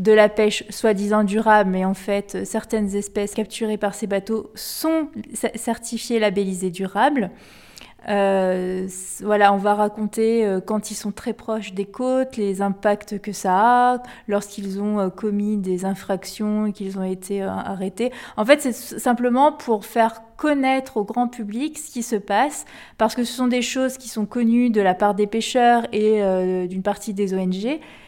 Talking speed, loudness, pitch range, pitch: 180 wpm, -21 LUFS, 200-235 Hz, 215 Hz